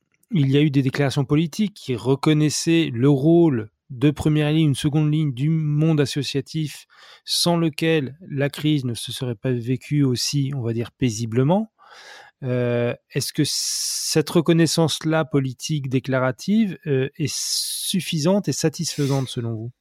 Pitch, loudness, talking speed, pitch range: 145 Hz, -21 LUFS, 145 wpm, 130-160 Hz